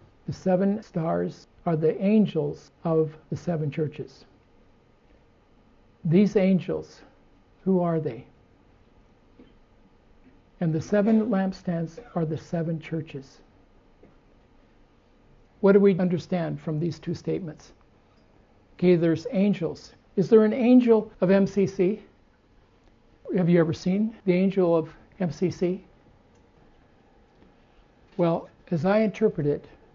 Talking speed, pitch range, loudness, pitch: 105 wpm, 155-195 Hz, -25 LUFS, 170 Hz